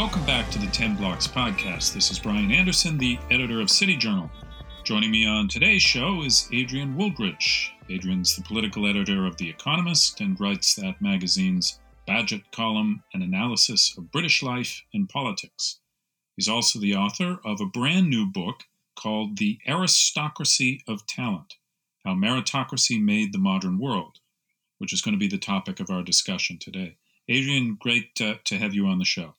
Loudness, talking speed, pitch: -23 LUFS, 170 wpm, 155 Hz